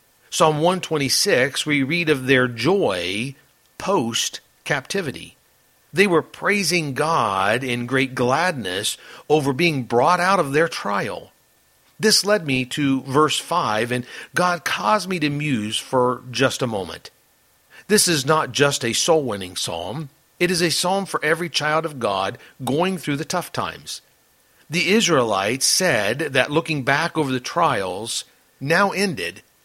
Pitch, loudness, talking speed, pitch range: 150 Hz, -20 LUFS, 145 wpm, 130-175 Hz